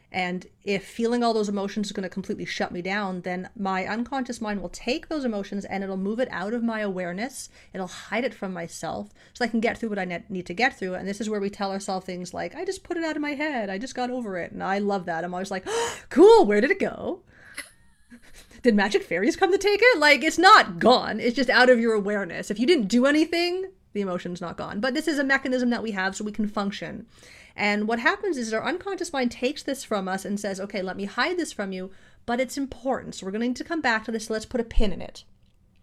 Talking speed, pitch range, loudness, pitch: 265 wpm, 195-265 Hz, -24 LUFS, 220 Hz